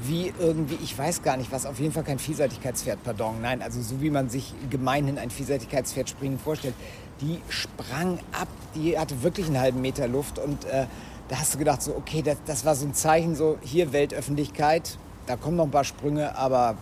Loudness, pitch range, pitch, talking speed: -27 LUFS, 130-155 Hz, 140 Hz, 205 wpm